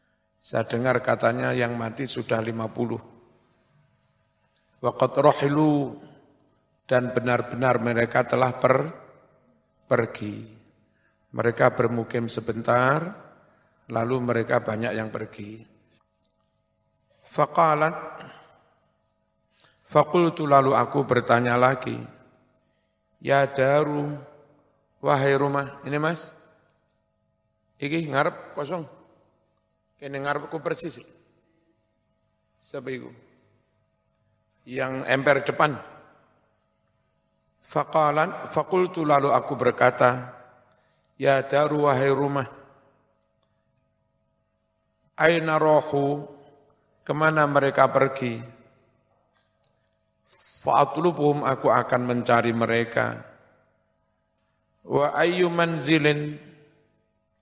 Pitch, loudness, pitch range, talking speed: 130 Hz, -23 LUFS, 110-145 Hz, 75 wpm